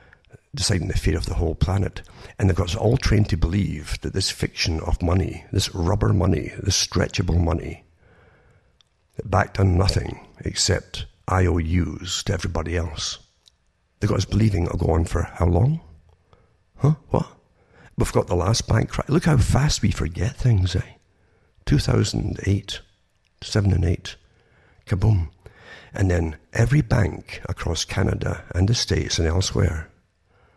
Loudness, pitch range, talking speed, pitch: -23 LUFS, 85-110 Hz, 145 wpm, 95 Hz